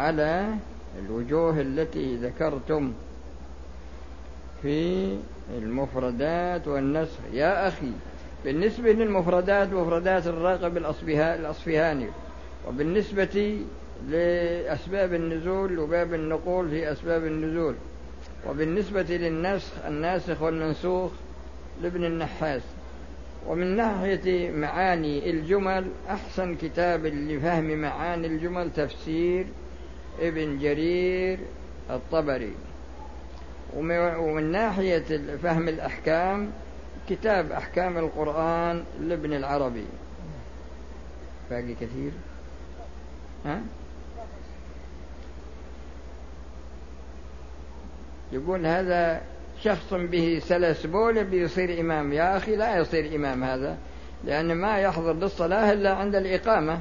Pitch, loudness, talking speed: 155 Hz, -27 LUFS, 80 wpm